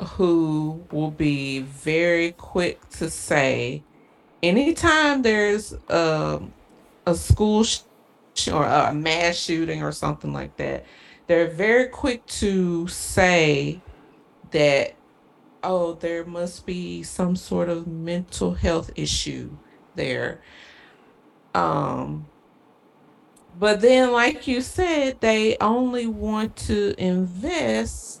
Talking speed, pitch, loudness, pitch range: 105 wpm, 175 Hz, -22 LUFS, 155-215 Hz